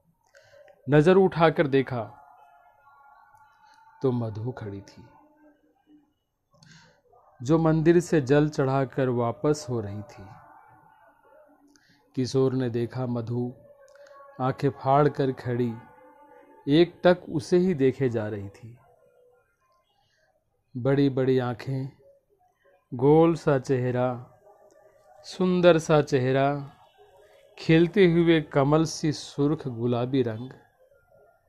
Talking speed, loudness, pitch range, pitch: 90 wpm, -24 LUFS, 130-185 Hz, 145 Hz